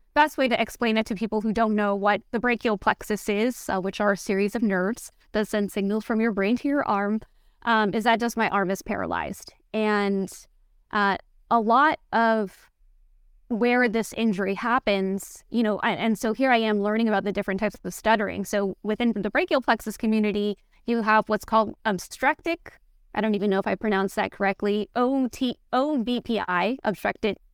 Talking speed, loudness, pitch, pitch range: 185 wpm, -25 LUFS, 215 Hz, 205-235 Hz